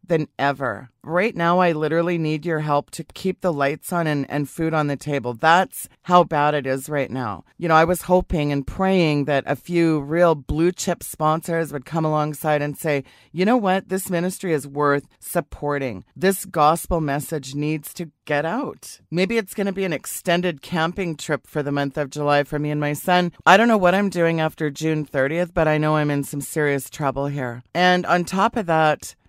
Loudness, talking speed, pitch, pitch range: -21 LUFS, 210 wpm, 155 Hz, 145-175 Hz